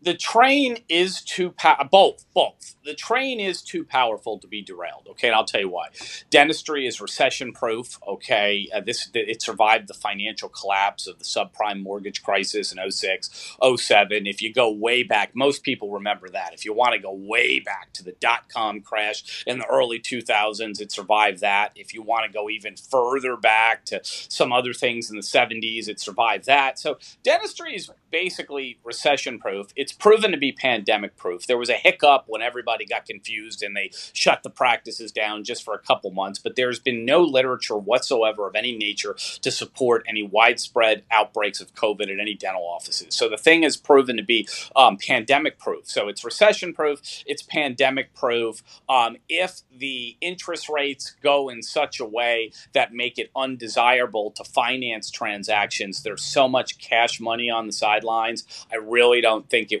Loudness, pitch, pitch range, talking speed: -22 LUFS, 120 Hz, 105-145 Hz, 185 wpm